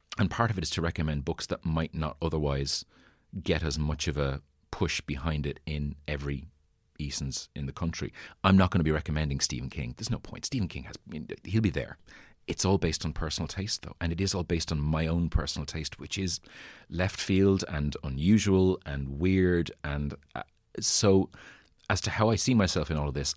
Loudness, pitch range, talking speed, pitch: -29 LUFS, 75-95 Hz, 215 wpm, 80 Hz